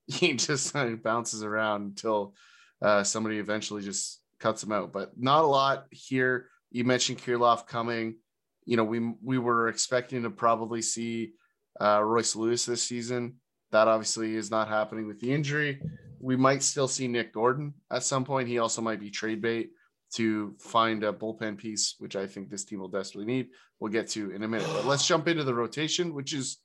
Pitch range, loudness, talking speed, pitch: 110-130 Hz, -29 LUFS, 195 wpm, 115 Hz